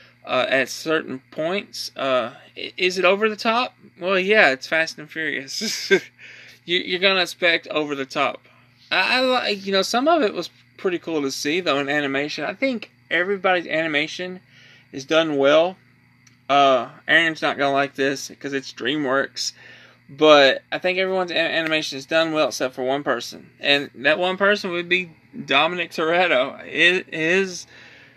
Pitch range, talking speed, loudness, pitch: 140-185 Hz, 165 wpm, -20 LUFS, 160 Hz